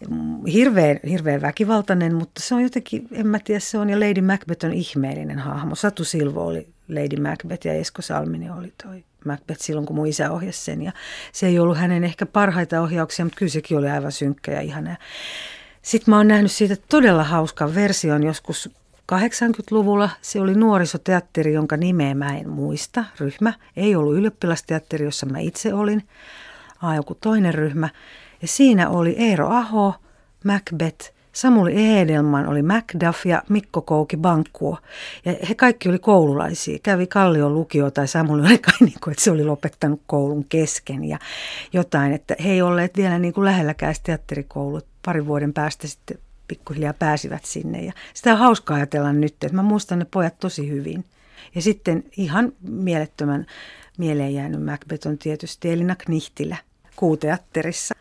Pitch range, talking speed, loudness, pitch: 150-200 Hz, 160 wpm, -20 LUFS, 170 Hz